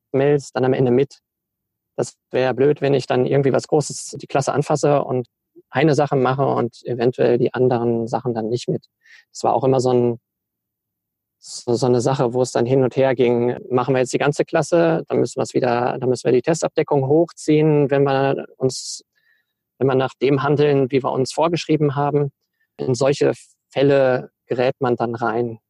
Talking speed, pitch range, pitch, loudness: 185 wpm, 125-145 Hz, 135 Hz, -19 LUFS